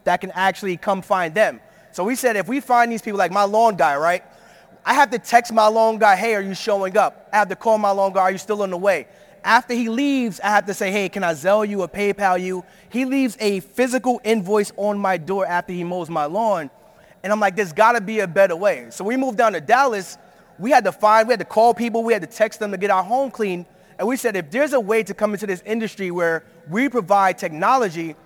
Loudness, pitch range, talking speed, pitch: -19 LUFS, 190-225 Hz, 260 wpm, 205 Hz